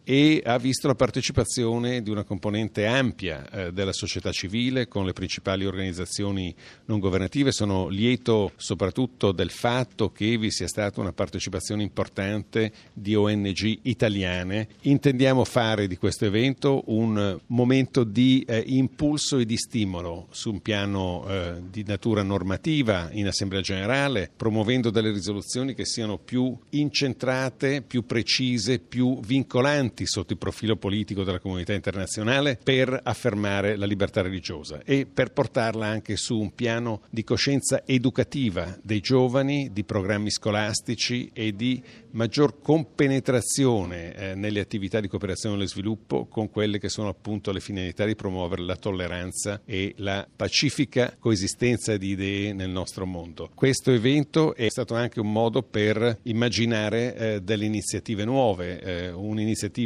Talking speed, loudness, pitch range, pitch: 140 wpm, -25 LUFS, 100-125 Hz, 110 Hz